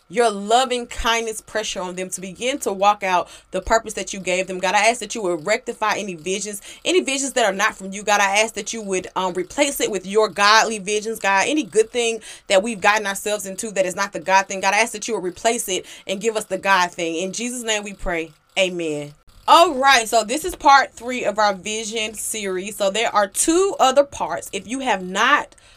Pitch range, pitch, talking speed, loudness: 190-230 Hz, 210 Hz, 240 wpm, -20 LUFS